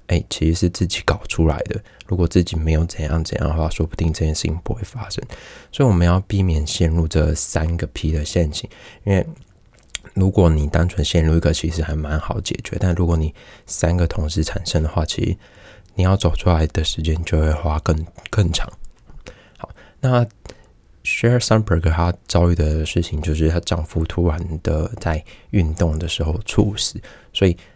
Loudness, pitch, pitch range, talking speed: -20 LUFS, 85 Hz, 80-100 Hz, 290 characters per minute